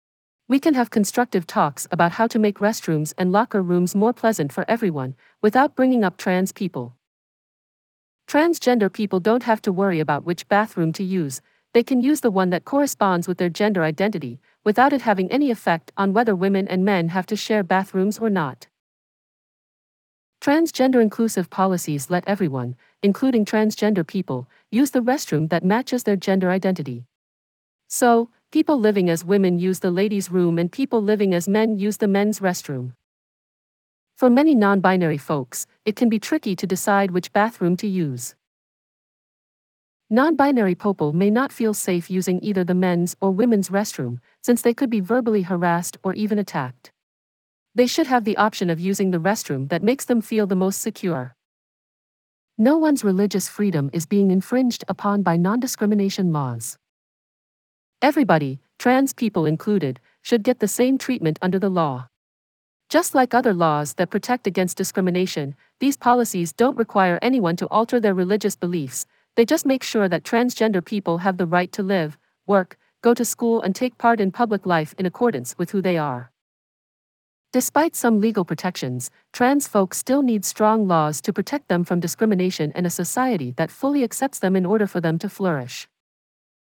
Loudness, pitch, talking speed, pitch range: -21 LUFS, 195 Hz, 170 wpm, 175-230 Hz